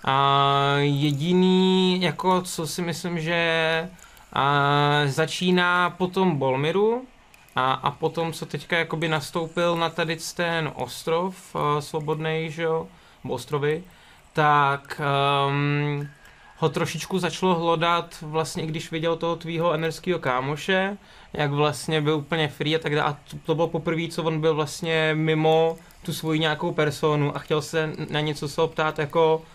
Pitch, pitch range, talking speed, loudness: 160 Hz, 150-170 Hz, 140 wpm, -24 LUFS